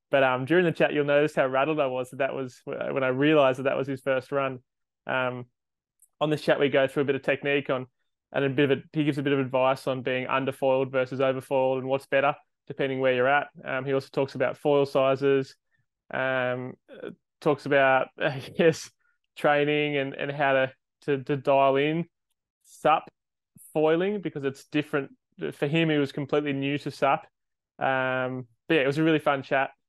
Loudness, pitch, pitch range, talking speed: -26 LUFS, 140 Hz, 130-150 Hz, 200 wpm